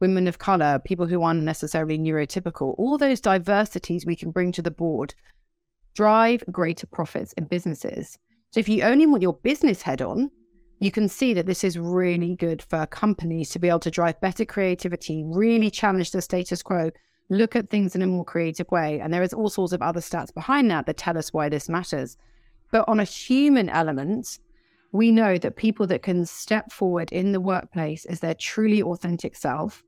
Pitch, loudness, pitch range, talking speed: 180 Hz, -24 LUFS, 170-215 Hz, 195 wpm